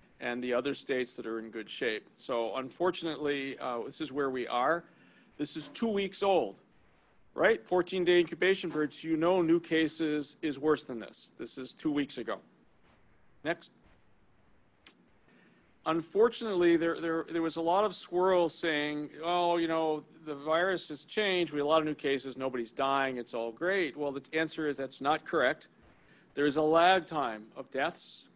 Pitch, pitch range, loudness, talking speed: 155 Hz, 135-170 Hz, -31 LUFS, 180 wpm